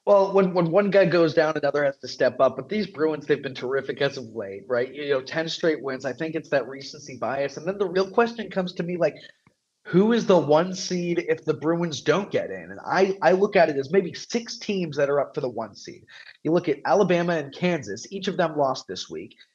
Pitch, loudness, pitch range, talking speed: 165 Hz, -24 LUFS, 140-190 Hz, 250 wpm